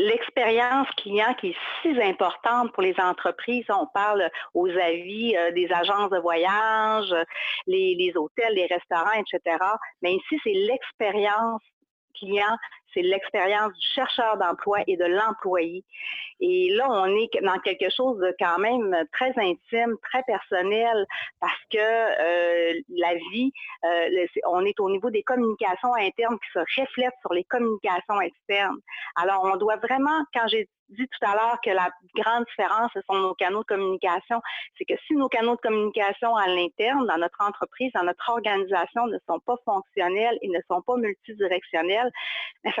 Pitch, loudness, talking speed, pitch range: 210 Hz, -25 LUFS, 165 wpm, 185-245 Hz